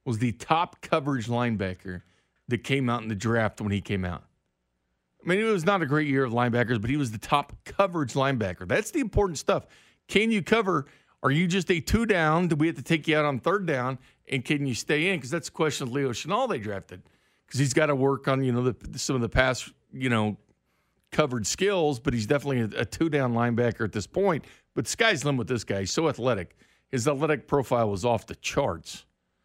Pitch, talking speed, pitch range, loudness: 130 Hz, 230 wpm, 115-155 Hz, -26 LUFS